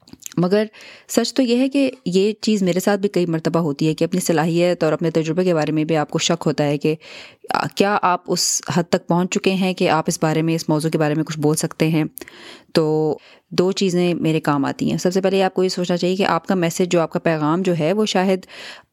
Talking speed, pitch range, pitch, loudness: 255 wpm, 160-190 Hz, 175 Hz, -19 LUFS